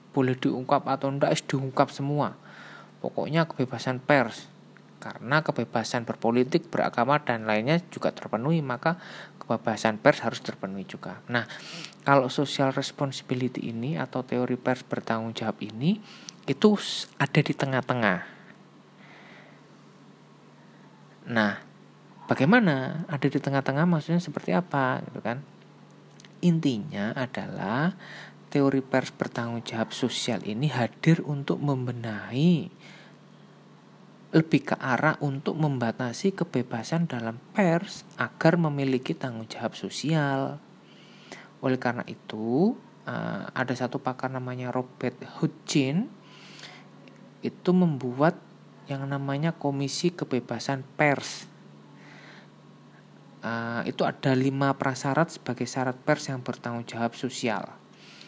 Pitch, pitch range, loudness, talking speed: 135 Hz, 125-155 Hz, -27 LUFS, 100 wpm